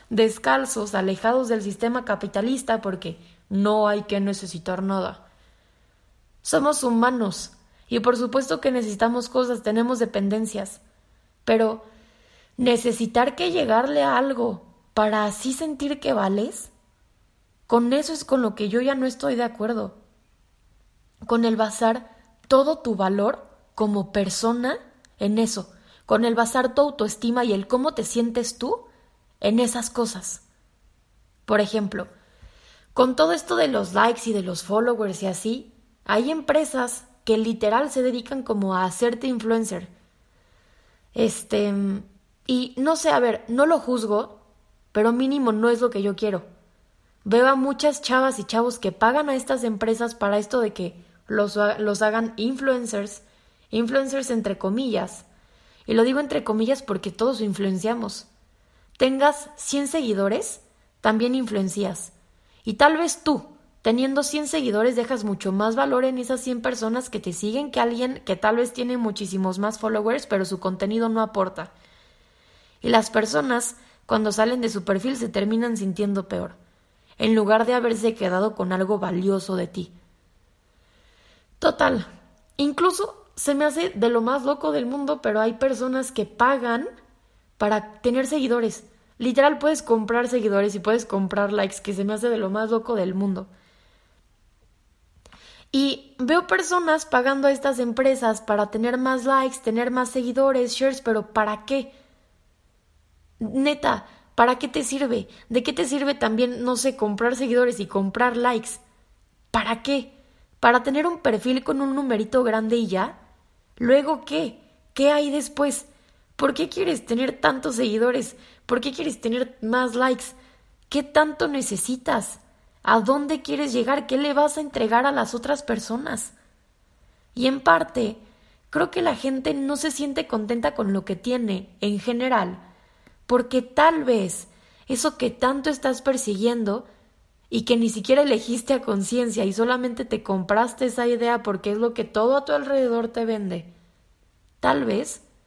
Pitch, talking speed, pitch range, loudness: 235 Hz, 150 wpm, 210-260 Hz, -23 LUFS